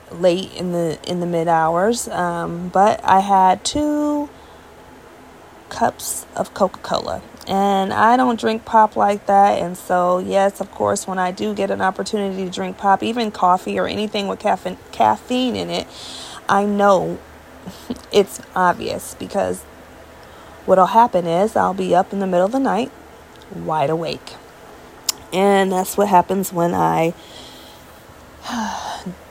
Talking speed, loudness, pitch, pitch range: 140 wpm, -18 LUFS, 190 Hz, 180-205 Hz